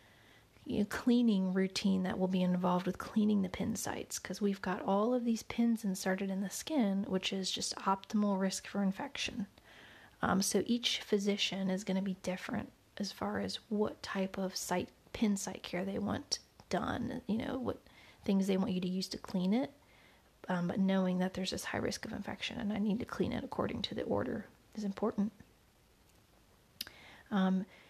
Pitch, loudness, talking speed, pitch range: 195 Hz, -35 LUFS, 185 wpm, 190-220 Hz